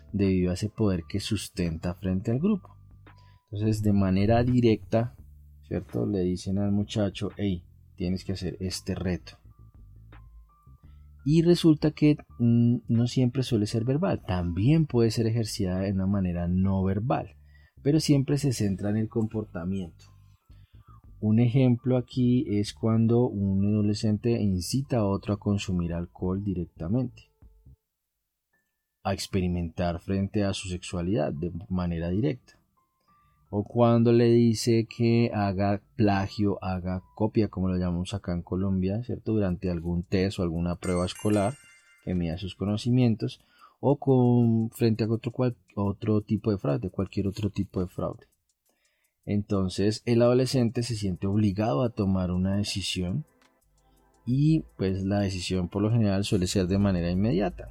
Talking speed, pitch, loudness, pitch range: 140 wpm, 100 Hz, -27 LUFS, 95-115 Hz